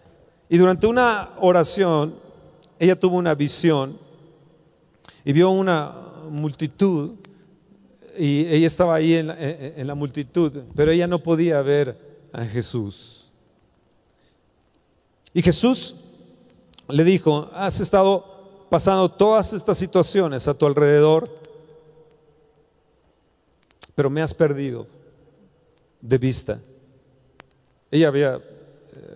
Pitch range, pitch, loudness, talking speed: 145-180 Hz, 160 Hz, -20 LUFS, 100 wpm